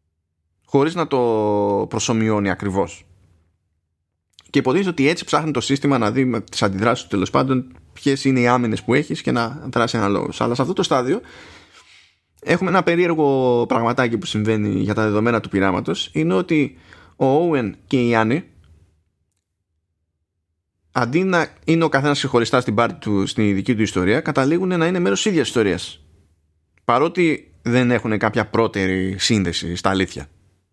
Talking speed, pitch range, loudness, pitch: 155 wpm, 90-130 Hz, -19 LUFS, 110 Hz